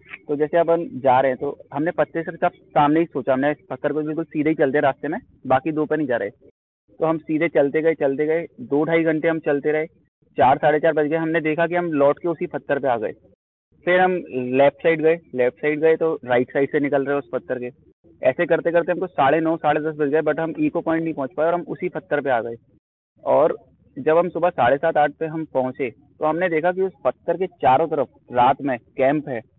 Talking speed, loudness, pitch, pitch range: 245 wpm, -21 LUFS, 155 Hz, 140-165 Hz